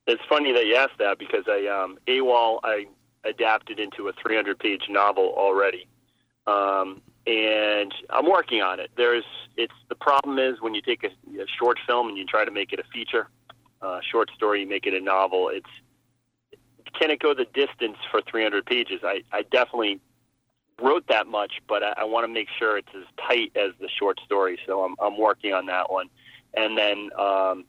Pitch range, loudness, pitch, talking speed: 100-130 Hz, -24 LUFS, 115 Hz, 200 wpm